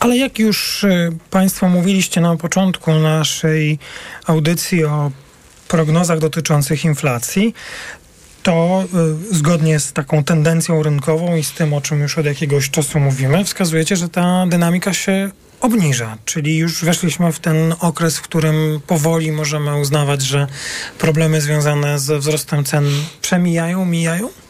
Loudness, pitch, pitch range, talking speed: -16 LUFS, 160 Hz, 150-175 Hz, 130 wpm